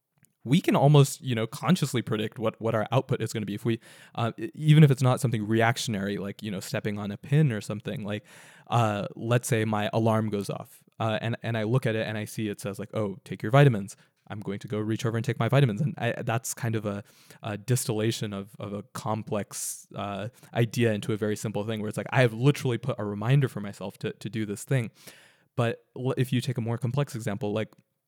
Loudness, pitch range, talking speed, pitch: -27 LUFS, 105-130 Hz, 240 wpm, 115 Hz